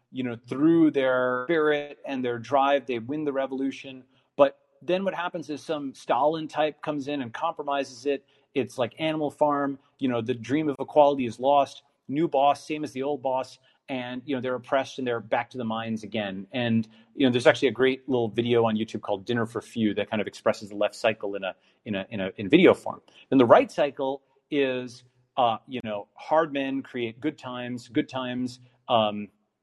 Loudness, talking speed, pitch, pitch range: -26 LUFS, 210 wpm, 130 Hz, 120-145 Hz